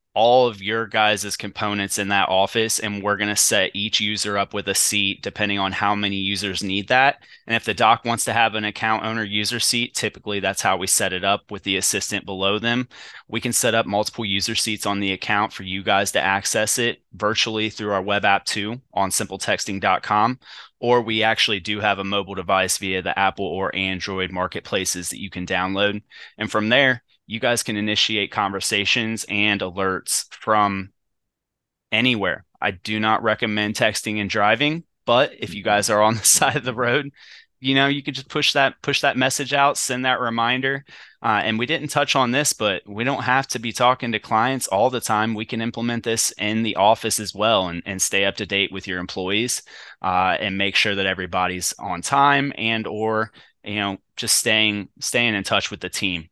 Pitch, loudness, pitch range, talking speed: 105 Hz, -20 LUFS, 100-115 Hz, 205 wpm